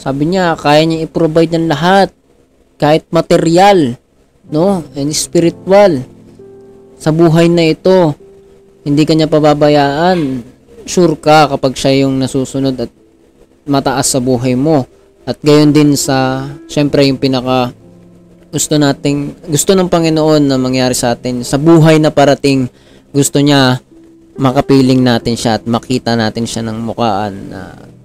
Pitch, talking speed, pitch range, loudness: 140 Hz, 130 wpm, 125-160 Hz, -11 LUFS